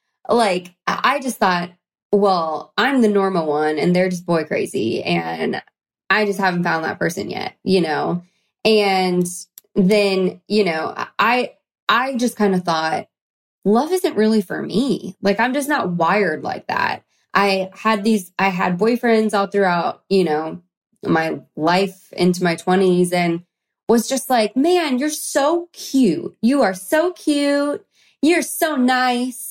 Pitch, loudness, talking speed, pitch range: 200 Hz, -19 LUFS, 155 wpm, 180-250 Hz